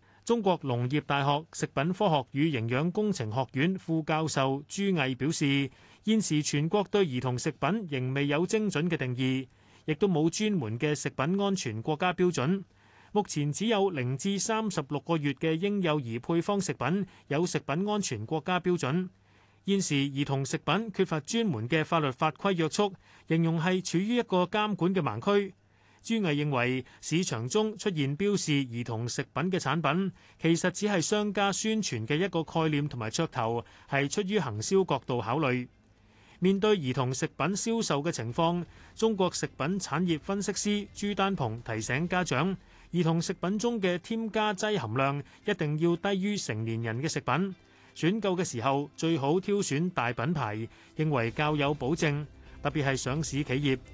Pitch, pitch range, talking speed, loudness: 160 Hz, 135-195 Hz, 255 characters per minute, -29 LUFS